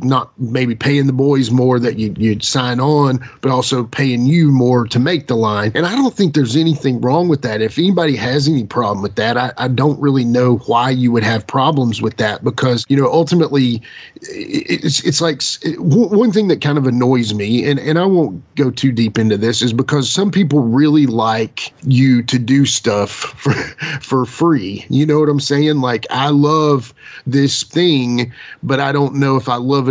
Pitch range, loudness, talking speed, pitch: 120-150 Hz, -15 LUFS, 205 wpm, 135 Hz